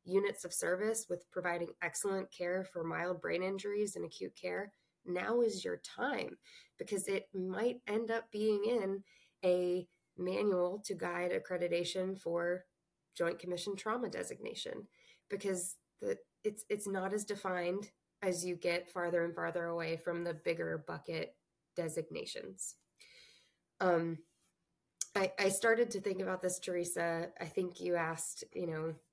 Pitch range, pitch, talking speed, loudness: 175-205 Hz, 185 Hz, 140 wpm, -37 LUFS